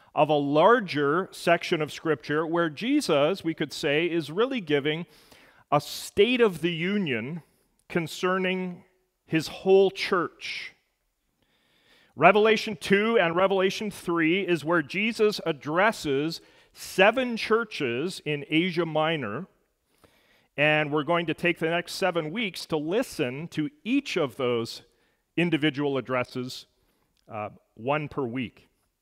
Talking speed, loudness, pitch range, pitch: 120 wpm, -25 LUFS, 150-190 Hz, 170 Hz